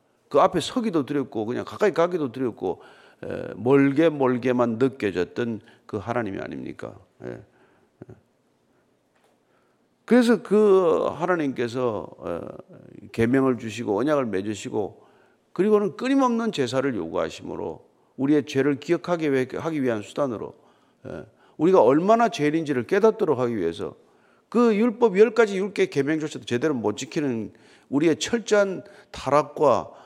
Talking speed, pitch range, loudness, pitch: 285 characters per minute, 125-200 Hz, -23 LUFS, 145 Hz